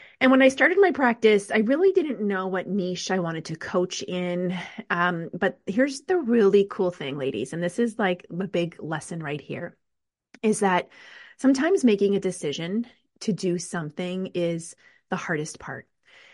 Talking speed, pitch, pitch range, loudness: 175 wpm, 190 Hz, 175-235 Hz, -24 LUFS